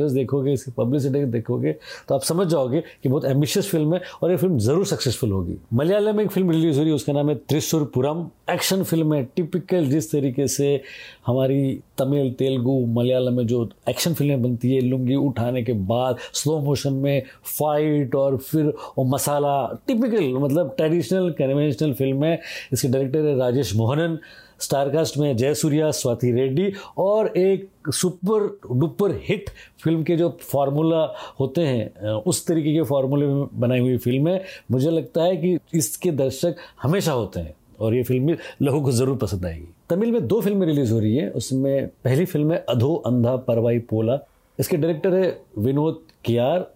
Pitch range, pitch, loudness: 125-165 Hz, 140 Hz, -22 LUFS